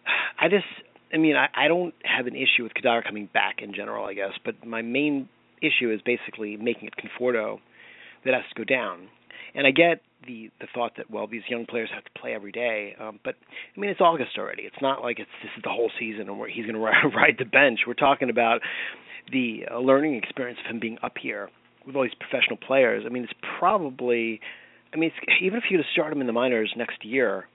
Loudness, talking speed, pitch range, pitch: -25 LUFS, 235 wpm, 115-140 Hz, 120 Hz